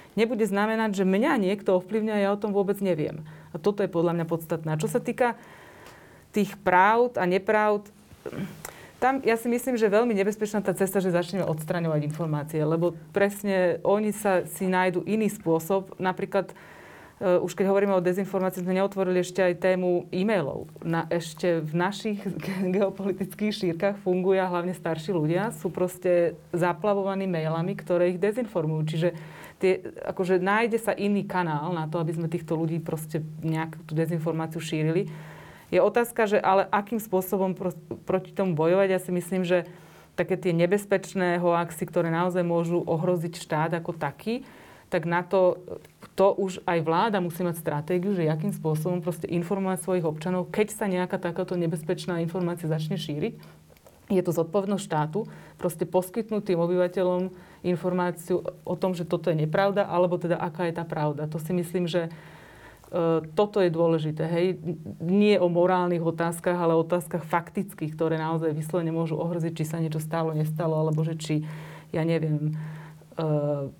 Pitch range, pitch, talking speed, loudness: 165-195 Hz, 180 Hz, 160 wpm, -26 LUFS